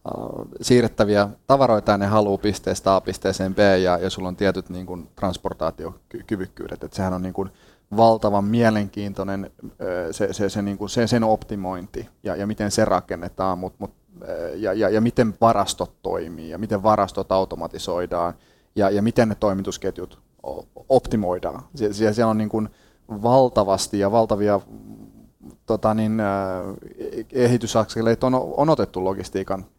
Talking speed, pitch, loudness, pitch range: 135 wpm, 100 Hz, -22 LUFS, 95-110 Hz